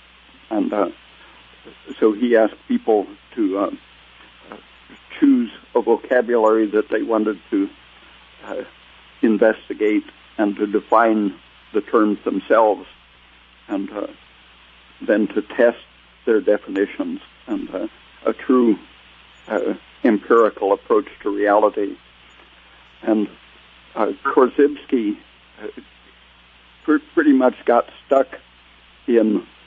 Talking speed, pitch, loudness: 95 wpm, 110 Hz, -19 LUFS